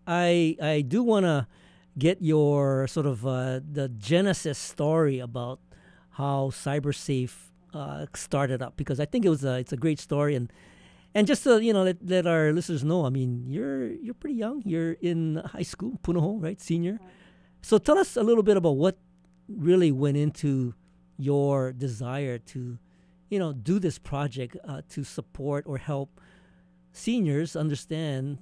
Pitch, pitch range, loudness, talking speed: 155 Hz, 135-180 Hz, -27 LUFS, 165 wpm